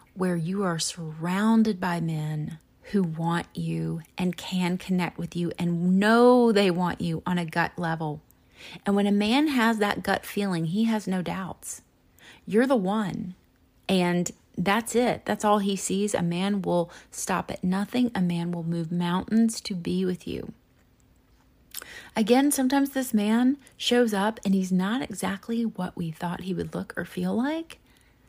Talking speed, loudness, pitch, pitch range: 170 wpm, -26 LUFS, 190 Hz, 175-220 Hz